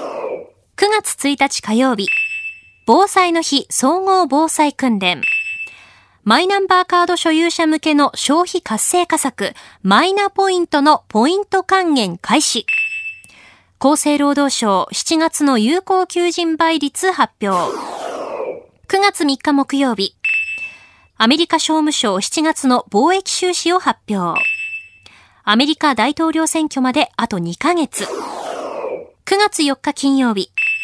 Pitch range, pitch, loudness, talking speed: 215-350 Hz, 295 Hz, -16 LUFS, 210 characters per minute